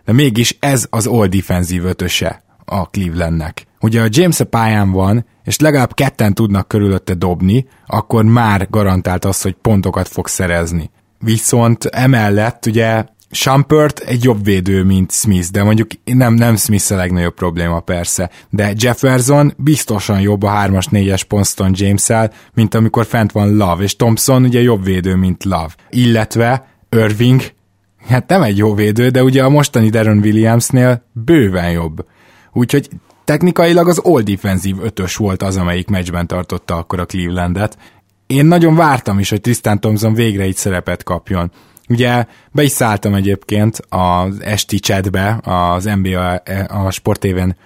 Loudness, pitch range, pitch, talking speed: -13 LUFS, 95-120 Hz, 105 Hz, 150 wpm